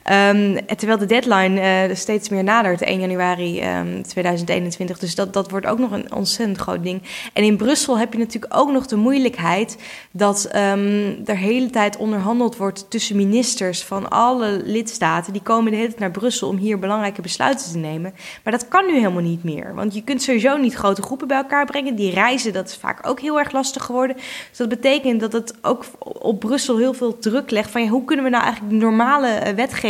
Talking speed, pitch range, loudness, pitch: 210 wpm, 195-245 Hz, -19 LUFS, 215 Hz